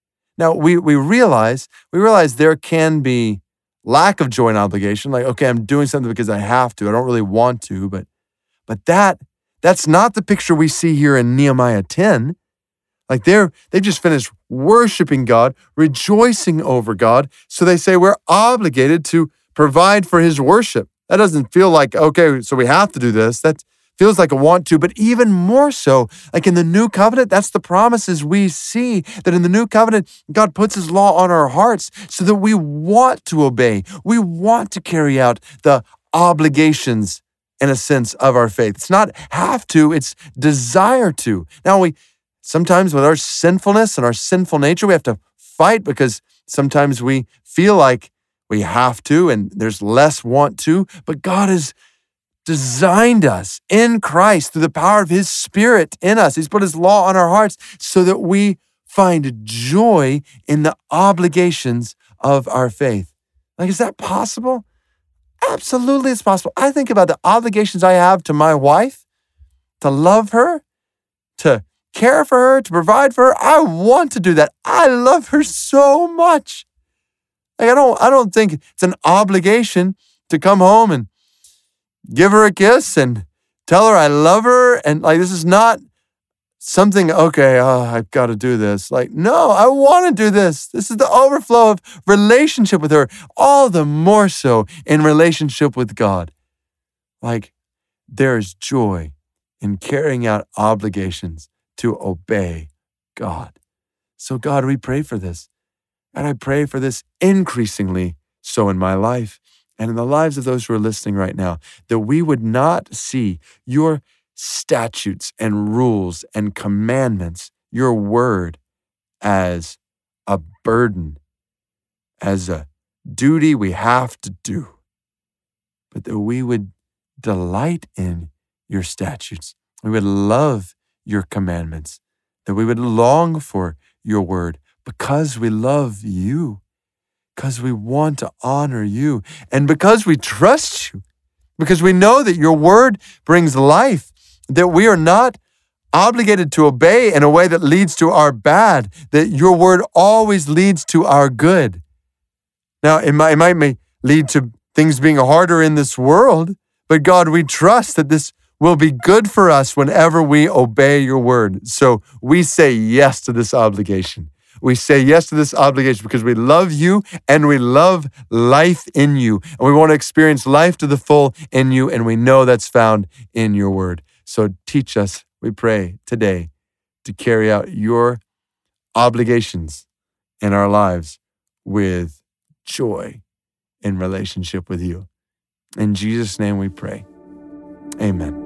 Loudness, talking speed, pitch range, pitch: -13 LUFS, 160 wpm, 110-180 Hz, 145 Hz